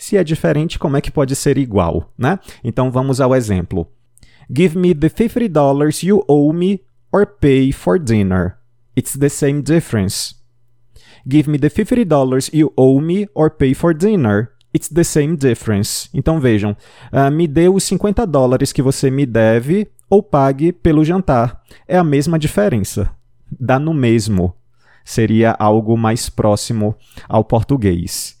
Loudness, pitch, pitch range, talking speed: -15 LUFS, 135 Hz, 115-160 Hz, 155 wpm